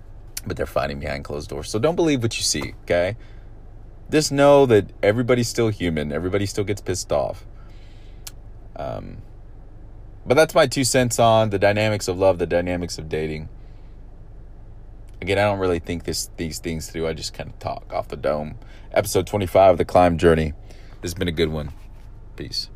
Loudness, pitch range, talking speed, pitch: -21 LUFS, 85-110 Hz, 185 wpm, 105 Hz